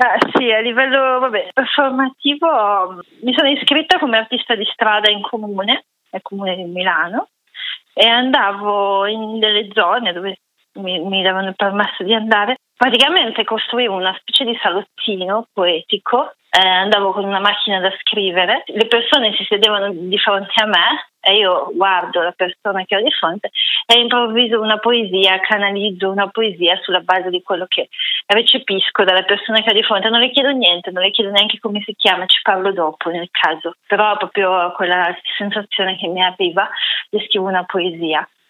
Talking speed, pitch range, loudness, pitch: 165 wpm, 190-230 Hz, -15 LUFS, 205 Hz